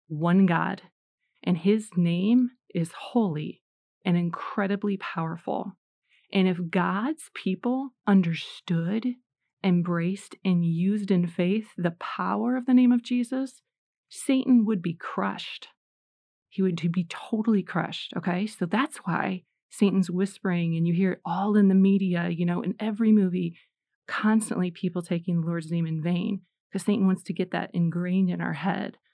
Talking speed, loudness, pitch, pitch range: 150 wpm, -26 LUFS, 190 Hz, 175-210 Hz